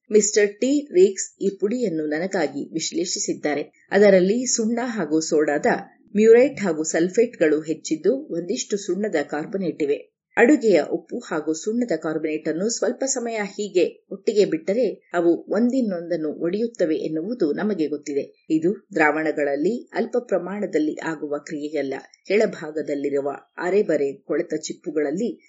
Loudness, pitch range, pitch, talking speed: -22 LUFS, 155-230 Hz, 185 Hz, 110 wpm